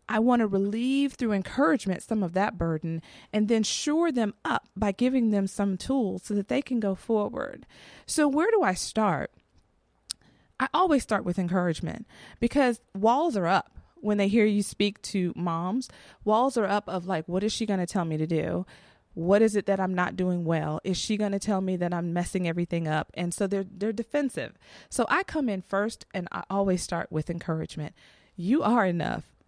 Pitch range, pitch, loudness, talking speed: 180-230 Hz, 200 Hz, -27 LUFS, 200 wpm